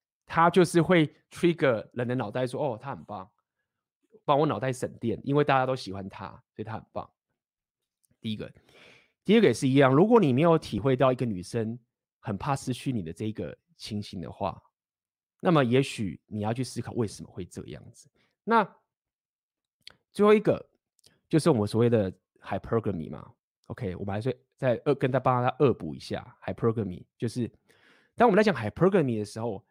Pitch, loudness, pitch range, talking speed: 125 Hz, -27 LUFS, 105-145 Hz, 315 characters per minute